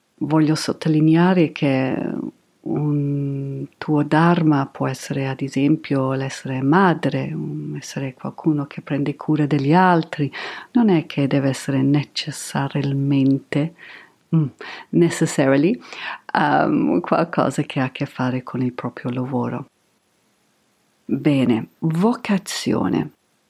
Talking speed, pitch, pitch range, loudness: 100 wpm, 145 Hz, 135-160 Hz, -20 LUFS